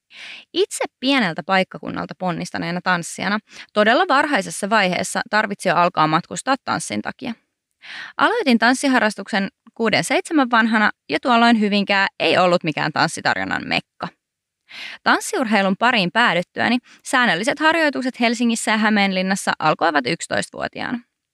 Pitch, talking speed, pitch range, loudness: 215 Hz, 100 wpm, 190-250 Hz, -19 LUFS